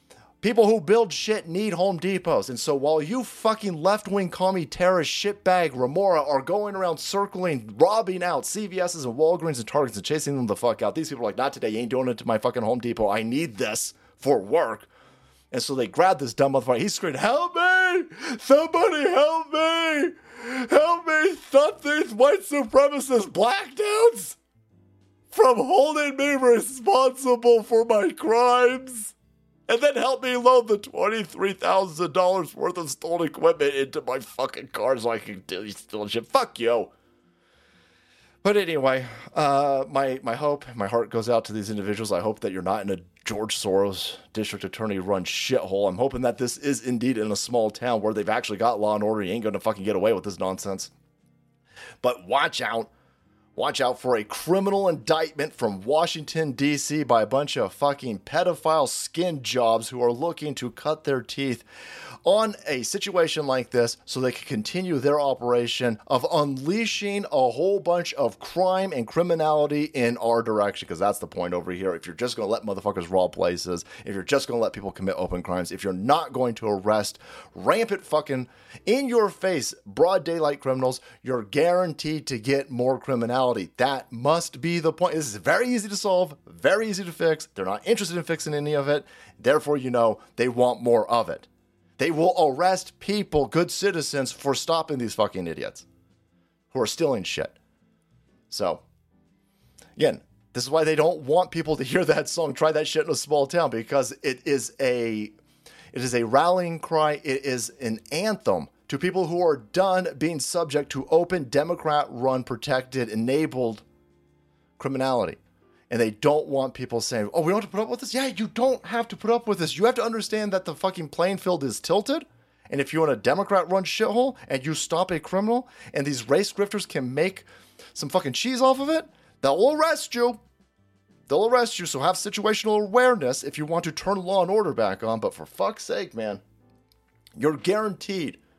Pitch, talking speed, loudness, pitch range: 155 Hz, 190 wpm, -24 LUFS, 125-205 Hz